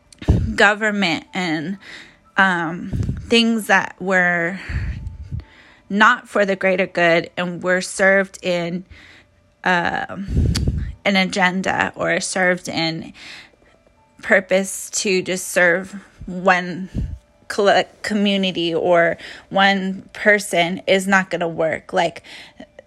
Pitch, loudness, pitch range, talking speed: 190 Hz, -18 LUFS, 175-195 Hz, 95 wpm